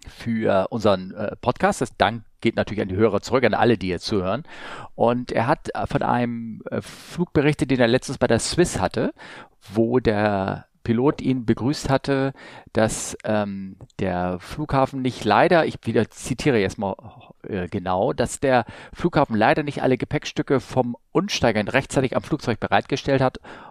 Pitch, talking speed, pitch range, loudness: 120 Hz, 155 wpm, 105-135 Hz, -22 LUFS